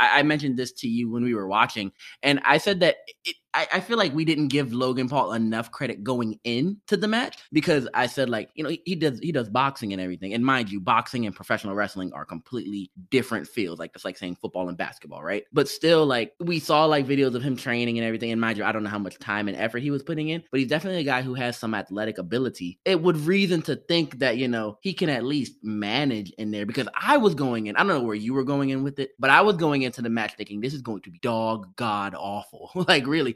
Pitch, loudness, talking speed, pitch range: 125 Hz, -25 LUFS, 265 wpm, 110-150 Hz